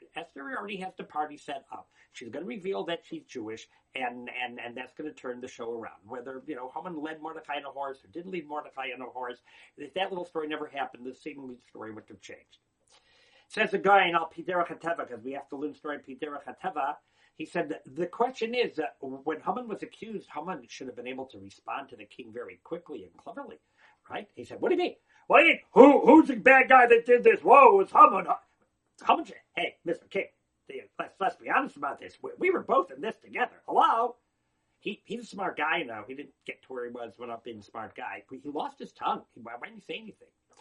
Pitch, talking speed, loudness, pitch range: 155 Hz, 235 wpm, -26 LUFS, 130-200 Hz